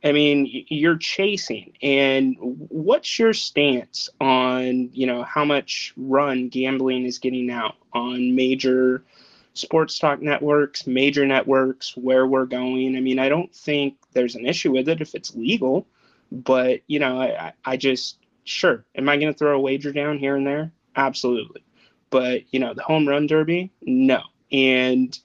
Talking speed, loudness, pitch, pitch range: 165 wpm, -21 LUFS, 135 Hz, 130-145 Hz